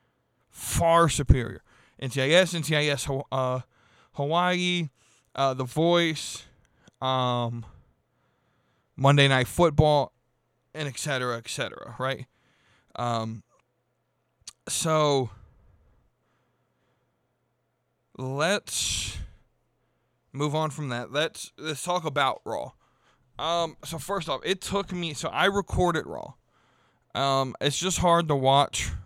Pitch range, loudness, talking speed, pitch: 125-160 Hz, -26 LUFS, 100 wpm, 135 Hz